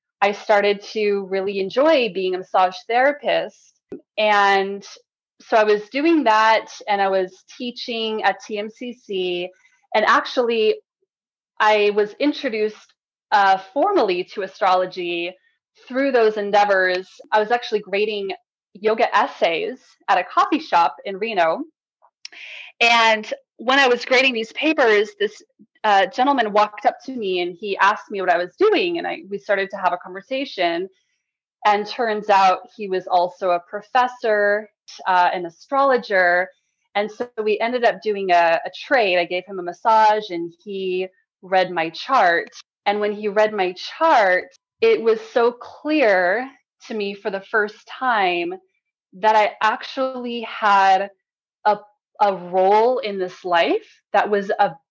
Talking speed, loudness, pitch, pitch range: 145 wpm, -19 LUFS, 210 Hz, 195-260 Hz